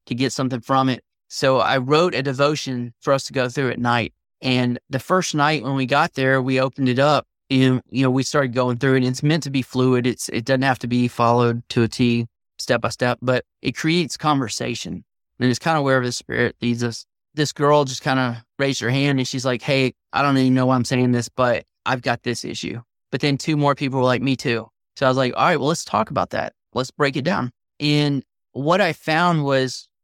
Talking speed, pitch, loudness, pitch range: 245 wpm, 130 Hz, -20 LUFS, 125-140 Hz